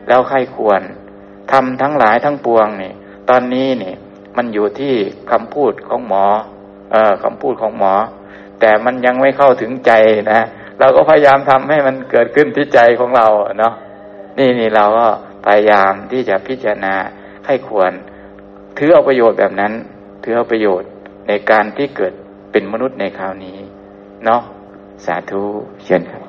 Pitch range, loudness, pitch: 100-125 Hz, -13 LUFS, 105 Hz